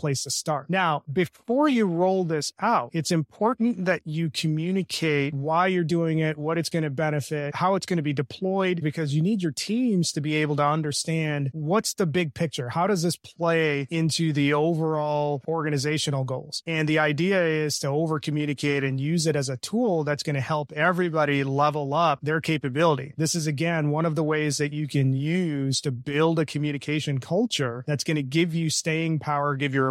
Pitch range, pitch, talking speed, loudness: 145-170 Hz, 155 Hz, 200 wpm, -25 LUFS